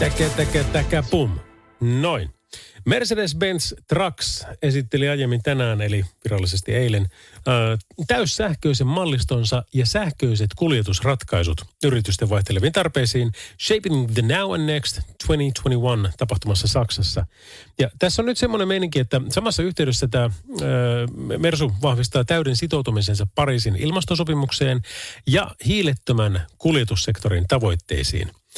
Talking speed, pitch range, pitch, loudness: 105 wpm, 105-150 Hz, 125 Hz, -21 LUFS